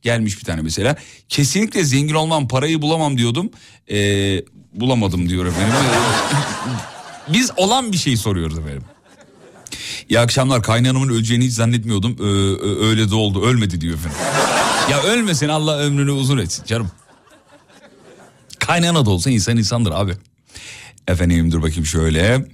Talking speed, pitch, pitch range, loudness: 135 wpm, 115 Hz, 100-140 Hz, -17 LUFS